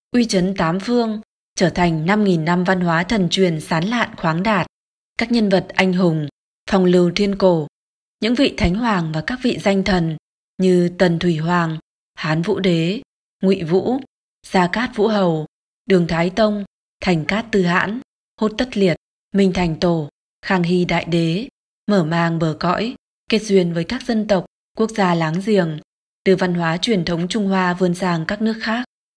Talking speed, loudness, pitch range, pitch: 185 wpm, -19 LUFS, 175-215 Hz, 185 Hz